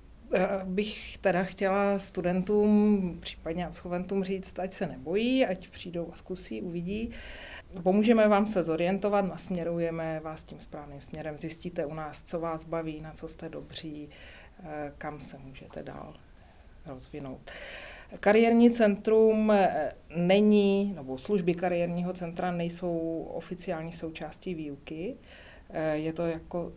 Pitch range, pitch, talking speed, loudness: 160-195 Hz, 180 Hz, 120 wpm, -29 LUFS